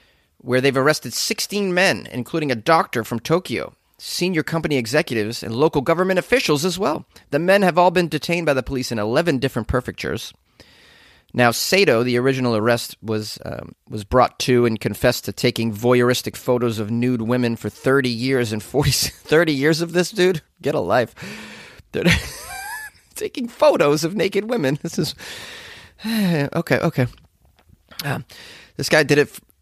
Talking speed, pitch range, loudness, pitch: 160 wpm, 120-170 Hz, -20 LUFS, 135 Hz